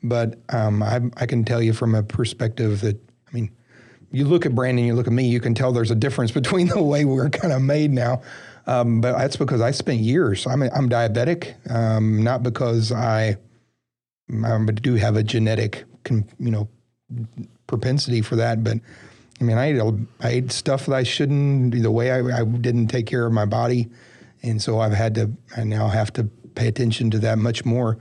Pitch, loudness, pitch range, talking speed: 120 Hz, -21 LUFS, 115-125 Hz, 205 wpm